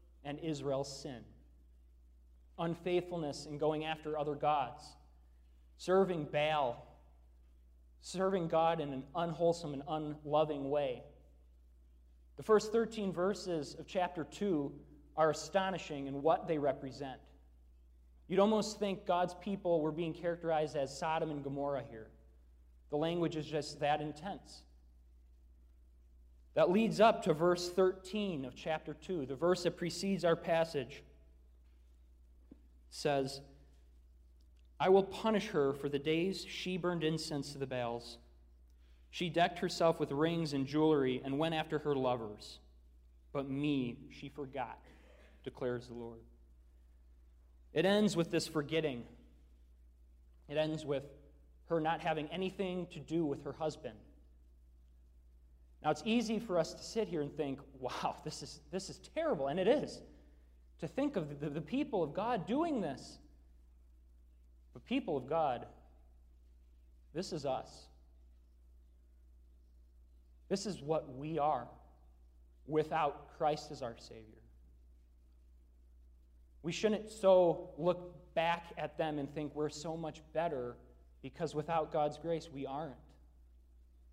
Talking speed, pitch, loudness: 130 wpm, 140 Hz, -36 LUFS